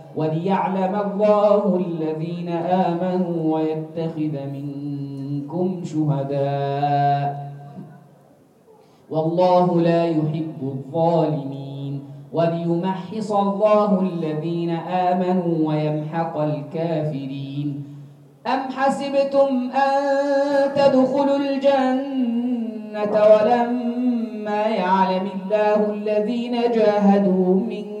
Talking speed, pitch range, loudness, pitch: 60 wpm, 155-215 Hz, -21 LUFS, 180 Hz